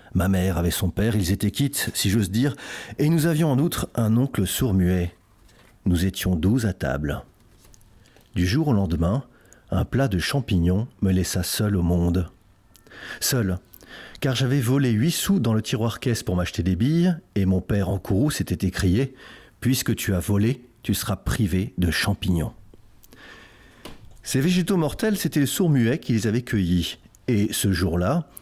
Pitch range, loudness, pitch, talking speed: 95-125 Hz, -23 LUFS, 105 Hz, 175 wpm